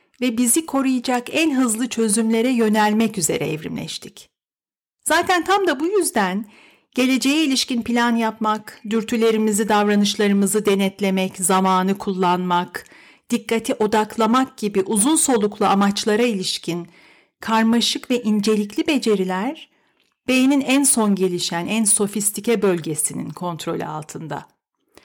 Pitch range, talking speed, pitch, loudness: 200-255 Hz, 105 wpm, 220 Hz, -19 LUFS